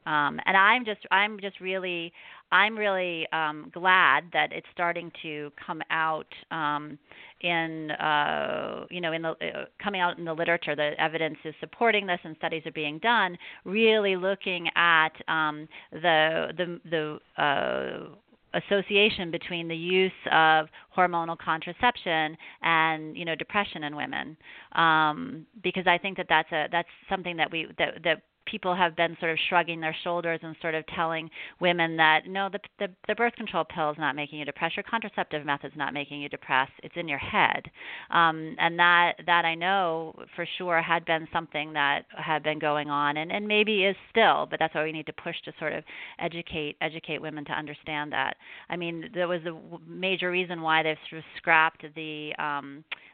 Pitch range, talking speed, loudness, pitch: 155-180 Hz, 185 wpm, -27 LUFS, 165 Hz